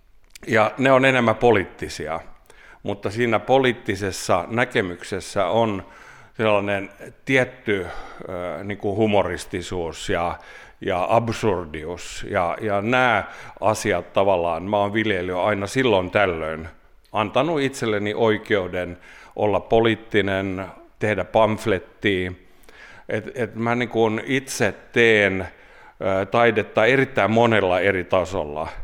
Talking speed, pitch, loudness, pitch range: 100 wpm, 105 Hz, -21 LUFS, 95-115 Hz